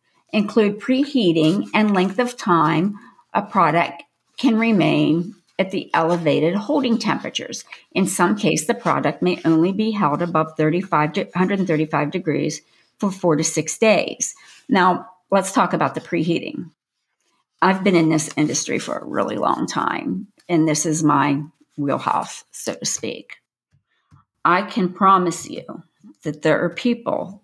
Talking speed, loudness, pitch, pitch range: 145 wpm, -20 LUFS, 175 Hz, 155-205 Hz